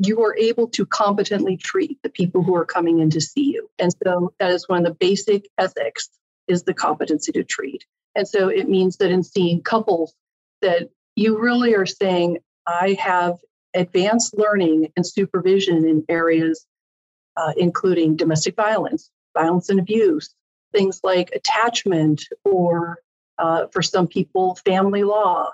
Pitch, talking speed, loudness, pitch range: 190 Hz, 155 wpm, -20 LUFS, 175-220 Hz